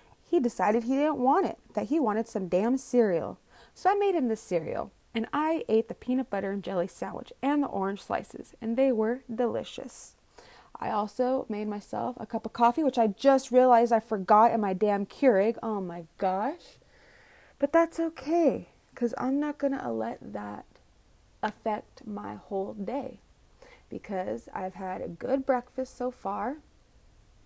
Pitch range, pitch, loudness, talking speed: 205-270 Hz, 235 Hz, -28 LUFS, 170 wpm